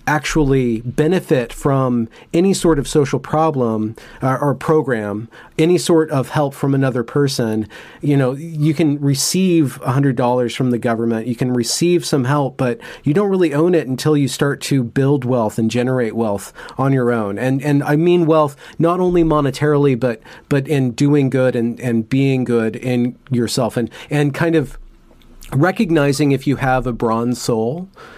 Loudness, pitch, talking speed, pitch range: -17 LUFS, 135 Hz, 170 wpm, 125-150 Hz